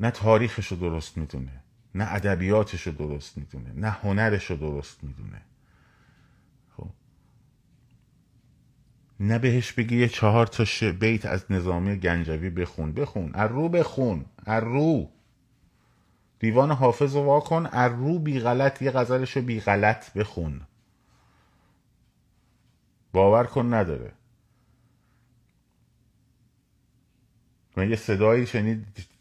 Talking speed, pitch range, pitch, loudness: 110 wpm, 95-125 Hz, 110 Hz, -25 LUFS